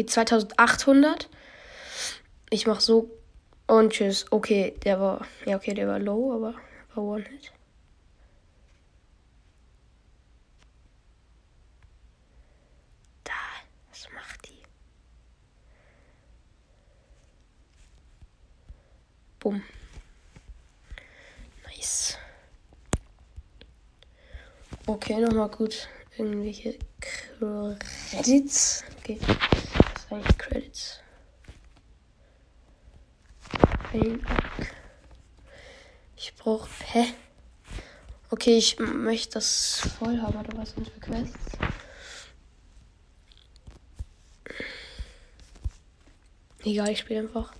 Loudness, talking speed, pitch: -26 LUFS, 65 wpm, 210 Hz